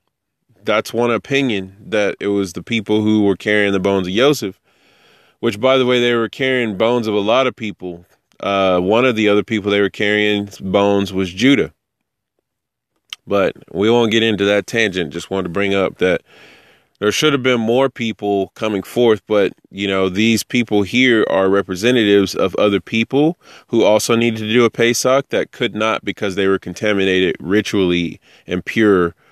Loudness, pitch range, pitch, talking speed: -16 LUFS, 100-115 Hz, 105 Hz, 180 wpm